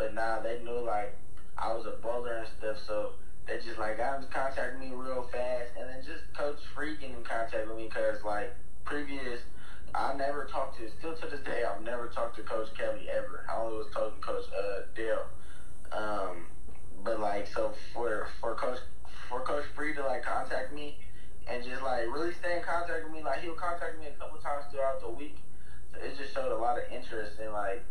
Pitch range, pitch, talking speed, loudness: 105-145 Hz, 120 Hz, 215 wpm, -36 LUFS